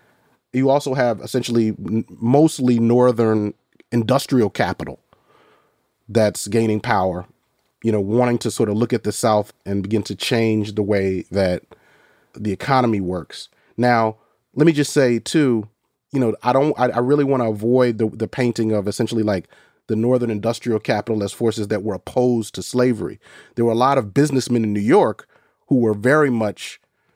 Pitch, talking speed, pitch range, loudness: 115 Hz, 170 wpm, 105-125 Hz, -19 LUFS